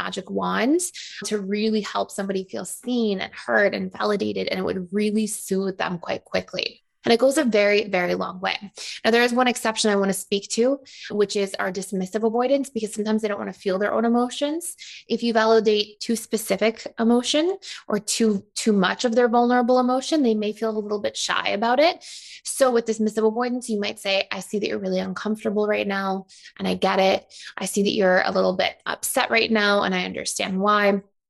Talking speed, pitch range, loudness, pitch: 210 wpm, 195-240 Hz, -23 LUFS, 215 Hz